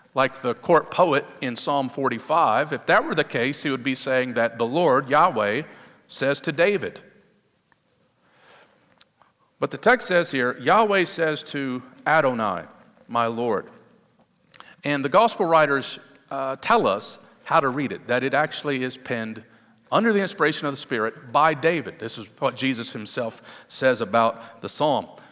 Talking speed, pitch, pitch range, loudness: 160 wpm, 135 Hz, 125-155 Hz, -23 LUFS